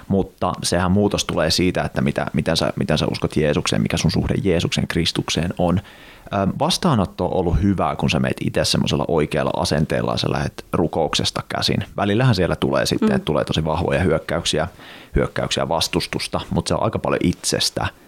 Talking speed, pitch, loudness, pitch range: 175 wpm, 90 Hz, -20 LUFS, 85-100 Hz